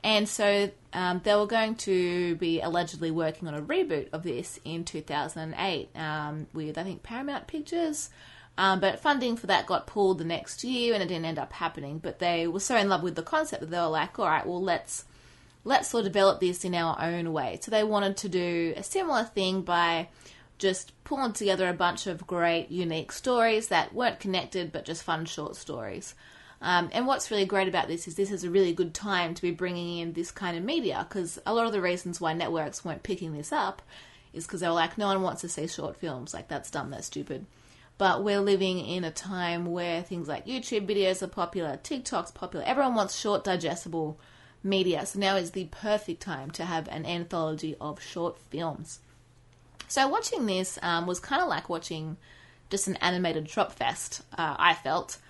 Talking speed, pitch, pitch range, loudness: 210 wpm, 180 Hz, 165-200 Hz, -29 LUFS